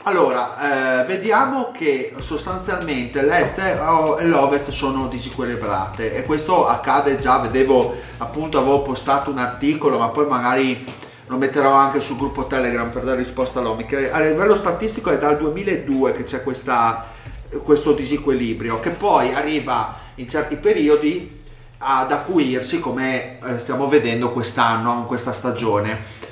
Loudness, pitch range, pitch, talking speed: -19 LUFS, 125-150 Hz, 130 Hz, 135 wpm